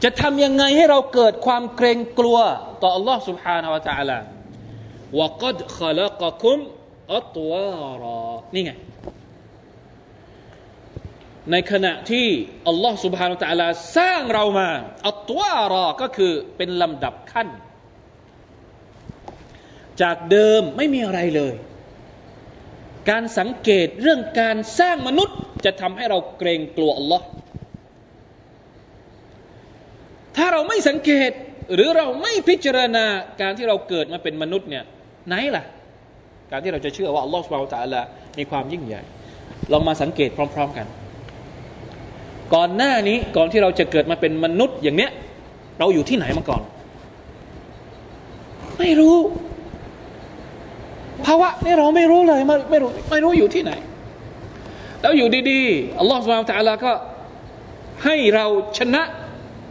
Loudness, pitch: -19 LUFS, 195 Hz